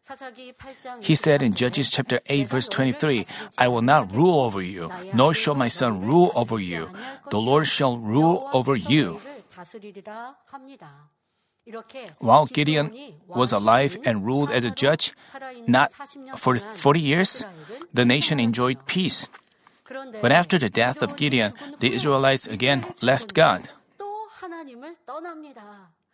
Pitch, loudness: 155 Hz, -21 LUFS